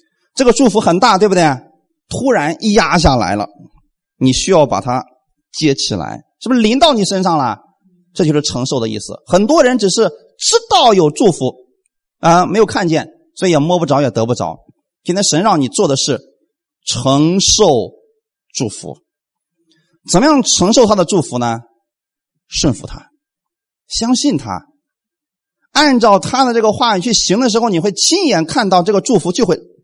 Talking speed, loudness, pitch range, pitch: 240 characters per minute, -13 LUFS, 150-255 Hz, 185 Hz